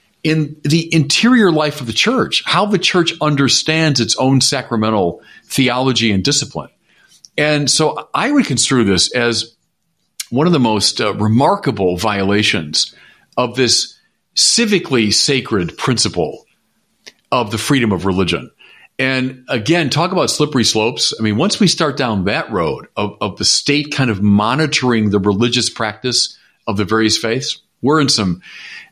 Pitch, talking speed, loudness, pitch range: 130 Hz, 150 wpm, -15 LUFS, 110-150 Hz